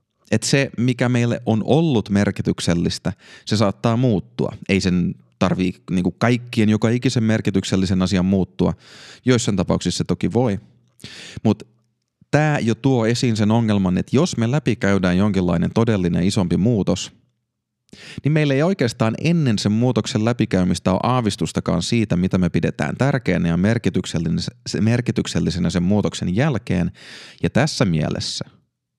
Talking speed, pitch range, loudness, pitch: 130 wpm, 95-120 Hz, -20 LUFS, 110 Hz